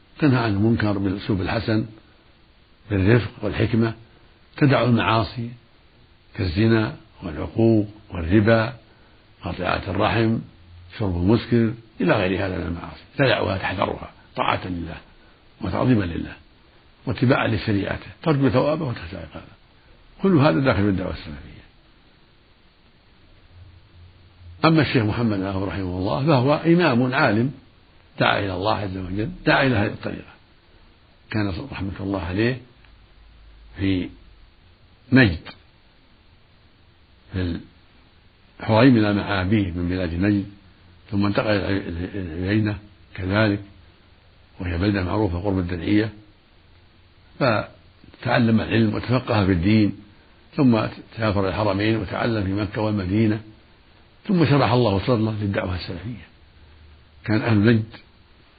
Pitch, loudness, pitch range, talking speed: 105 Hz, -22 LUFS, 90-115 Hz, 100 wpm